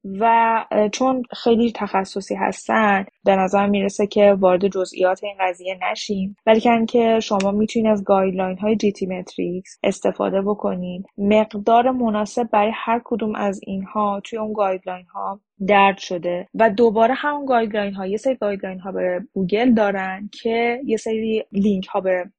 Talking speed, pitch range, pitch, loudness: 145 wpm, 195-225 Hz, 205 Hz, -20 LUFS